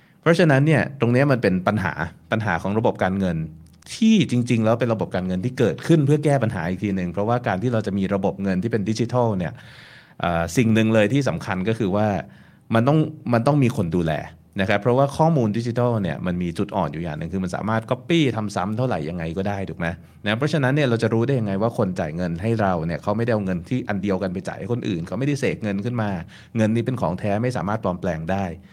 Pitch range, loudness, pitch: 95-125 Hz, -22 LUFS, 110 Hz